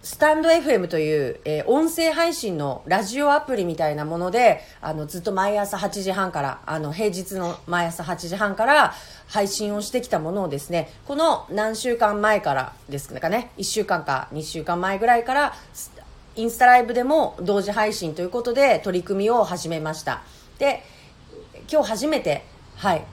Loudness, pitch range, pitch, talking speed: -22 LUFS, 170-240 Hz, 200 Hz, 315 characters per minute